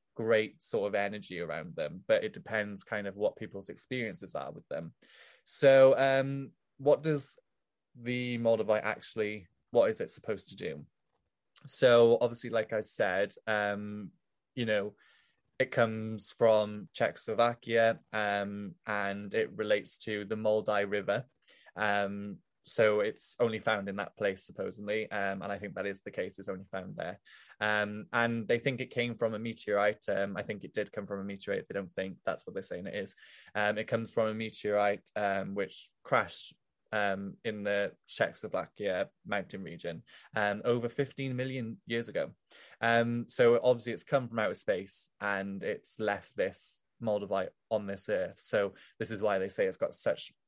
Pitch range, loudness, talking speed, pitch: 100-115 Hz, -32 LUFS, 170 wpm, 110 Hz